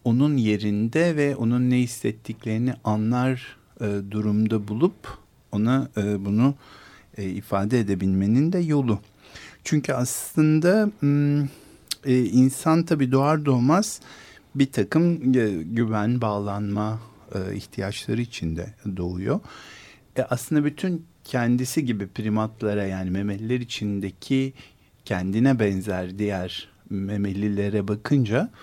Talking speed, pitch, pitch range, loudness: 105 wpm, 115 Hz, 105-135 Hz, -24 LUFS